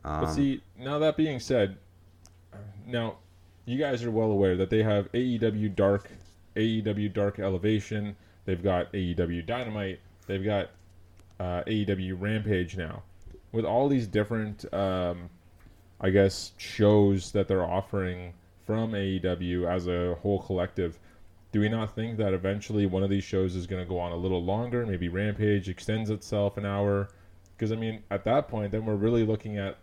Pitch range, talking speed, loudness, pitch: 90-105 Hz, 165 wpm, -29 LUFS, 100 Hz